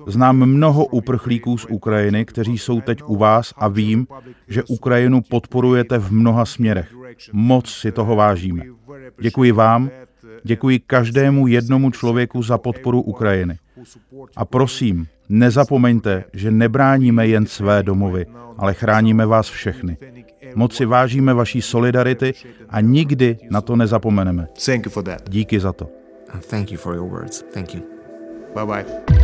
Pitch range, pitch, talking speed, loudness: 105-125 Hz, 115 Hz, 115 wpm, -17 LUFS